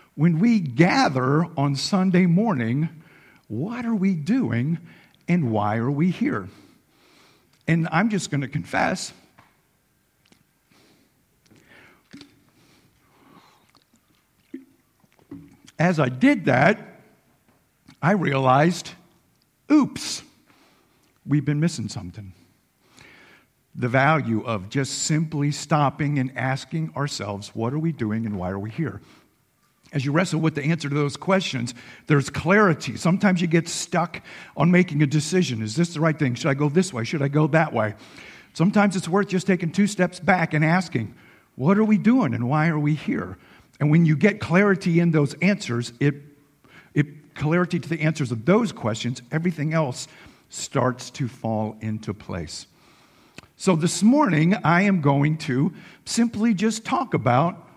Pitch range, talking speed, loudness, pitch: 130-180 Hz, 140 wpm, -22 LUFS, 155 Hz